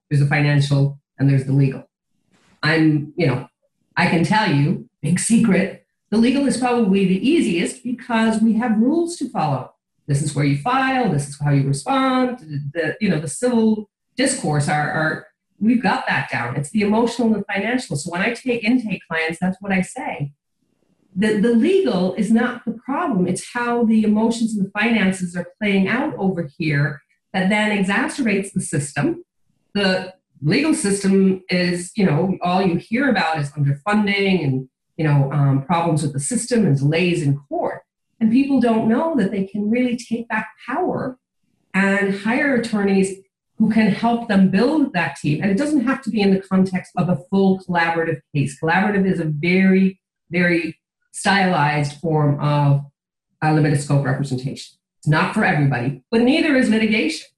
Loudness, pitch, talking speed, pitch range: -19 LUFS, 190 Hz, 175 wpm, 155-225 Hz